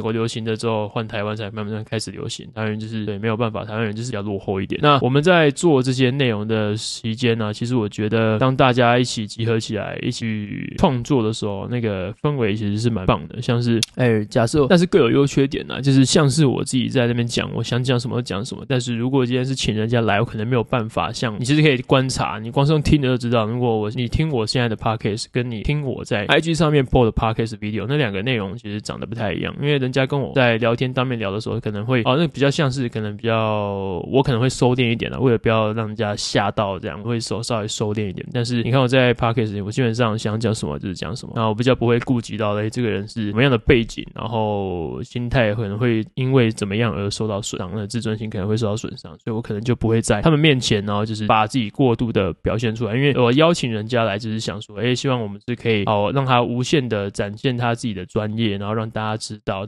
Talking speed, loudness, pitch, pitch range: 405 characters per minute, -20 LUFS, 115 Hz, 110-125 Hz